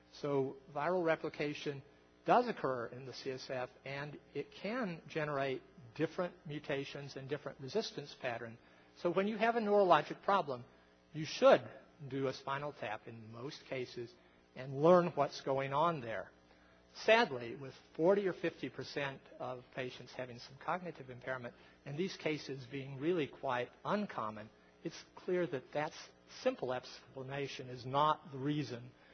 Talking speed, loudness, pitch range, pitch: 140 wpm, -37 LUFS, 125-160 Hz, 140 Hz